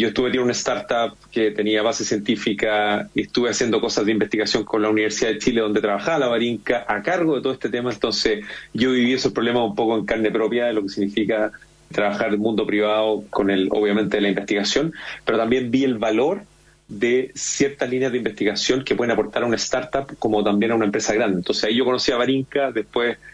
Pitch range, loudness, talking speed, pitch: 105-125 Hz, -21 LUFS, 215 wpm, 110 Hz